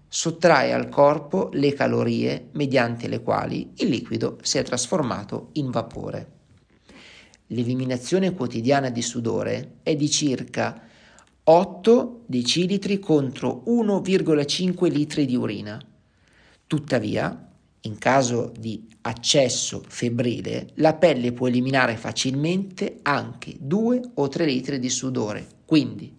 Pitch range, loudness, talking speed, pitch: 120-160 Hz, -23 LUFS, 110 wpm, 135 Hz